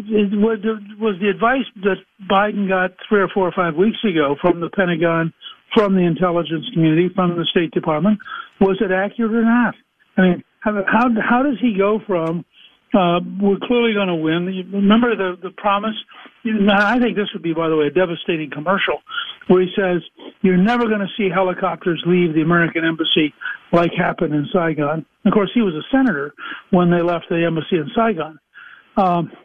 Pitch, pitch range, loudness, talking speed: 190 Hz, 170-210 Hz, -18 LUFS, 185 wpm